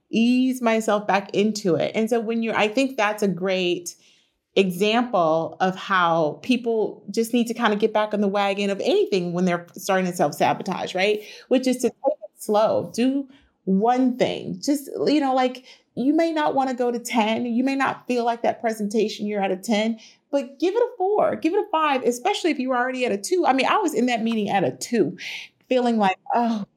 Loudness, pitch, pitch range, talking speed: -22 LUFS, 230 Hz, 200-255 Hz, 215 wpm